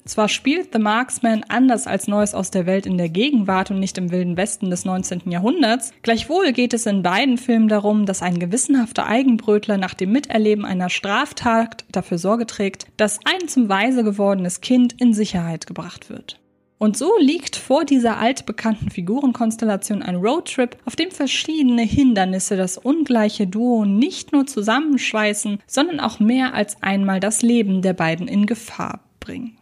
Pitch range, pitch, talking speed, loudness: 195-250 Hz, 215 Hz, 165 wpm, -19 LUFS